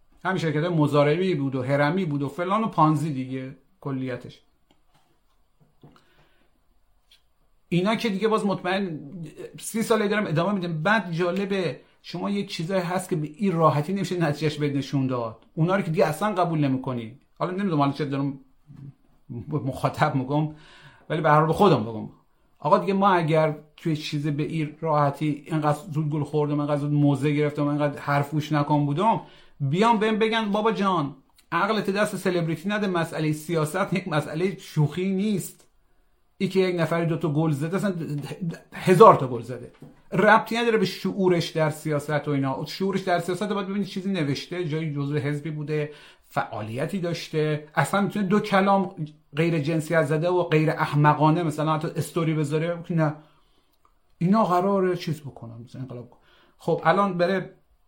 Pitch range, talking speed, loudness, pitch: 145-185 Hz, 155 wpm, -24 LUFS, 160 Hz